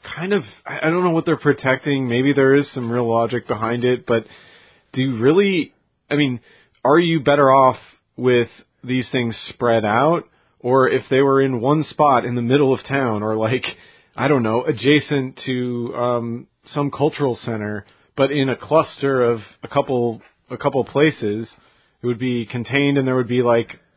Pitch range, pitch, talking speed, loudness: 120-140 Hz, 130 Hz, 185 wpm, -19 LUFS